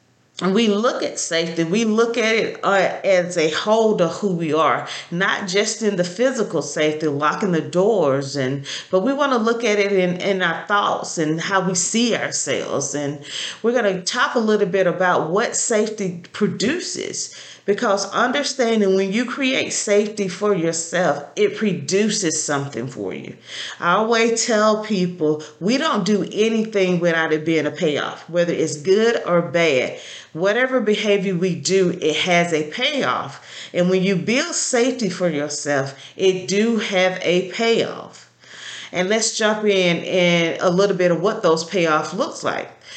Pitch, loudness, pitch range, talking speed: 190 Hz, -19 LUFS, 170-215 Hz, 170 wpm